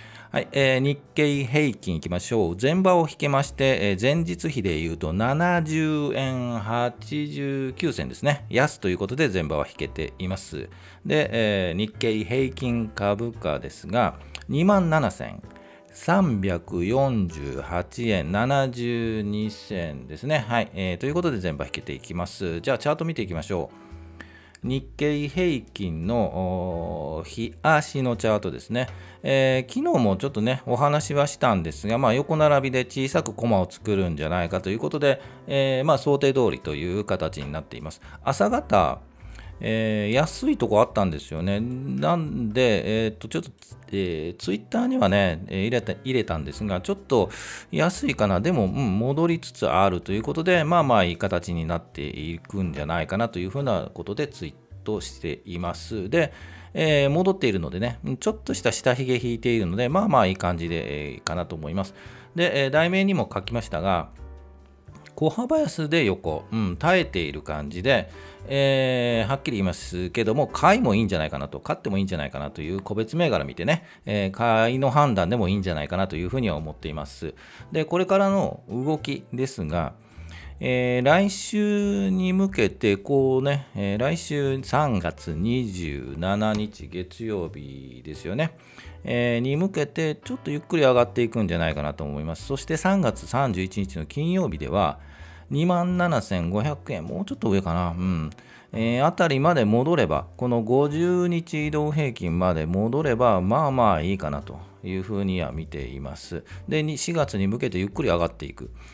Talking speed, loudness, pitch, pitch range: 325 characters per minute, -24 LUFS, 110 Hz, 85-140 Hz